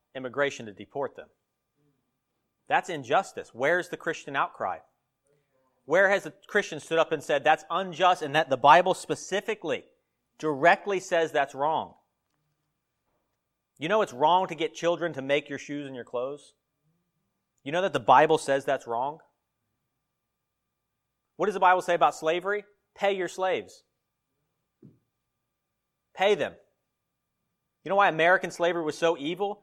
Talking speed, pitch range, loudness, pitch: 145 wpm, 145-180 Hz, -26 LUFS, 155 Hz